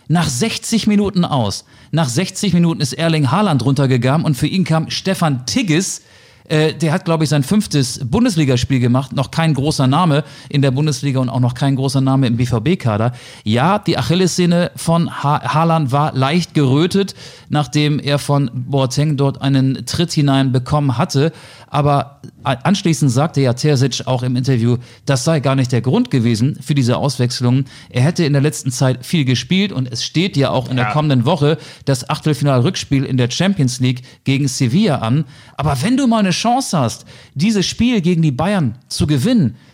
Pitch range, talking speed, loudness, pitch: 130-165 Hz, 180 wpm, -16 LUFS, 140 Hz